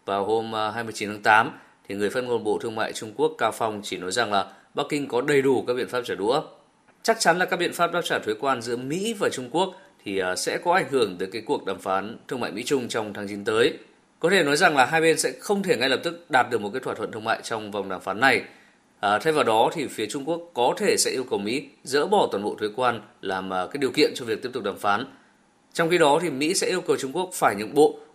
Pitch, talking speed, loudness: 155 Hz, 280 wpm, -24 LUFS